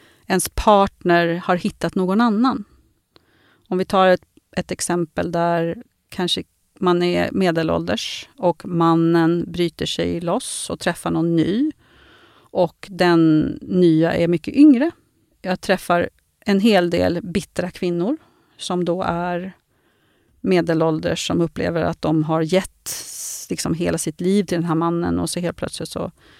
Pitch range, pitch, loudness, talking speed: 170-190 Hz, 175 Hz, -20 LUFS, 140 wpm